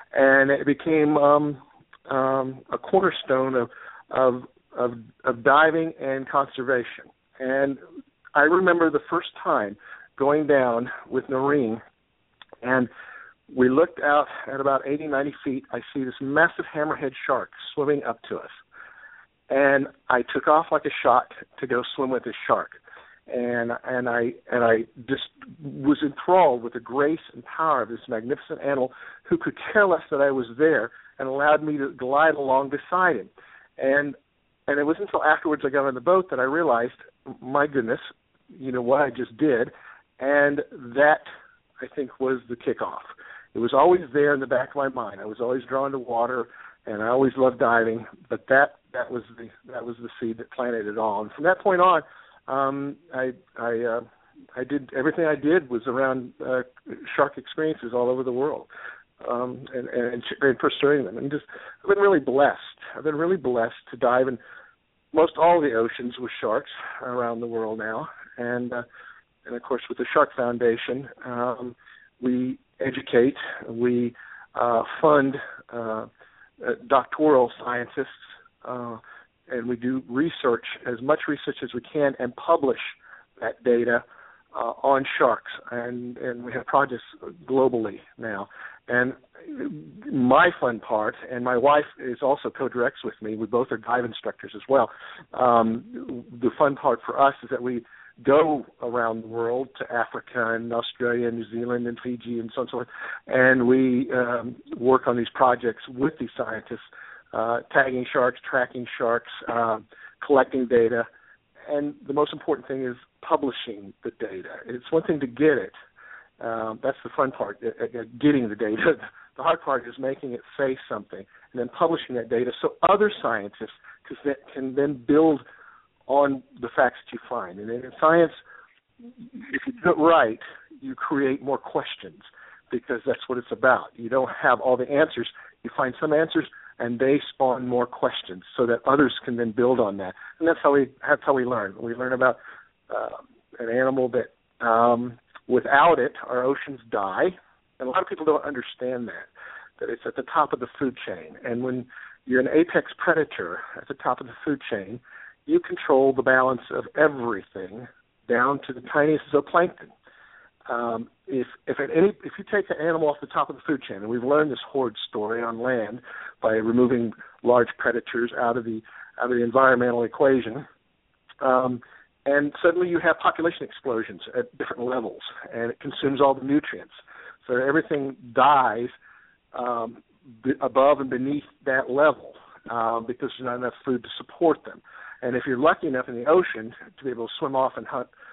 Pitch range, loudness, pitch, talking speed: 120-145 Hz, -24 LUFS, 130 Hz, 175 wpm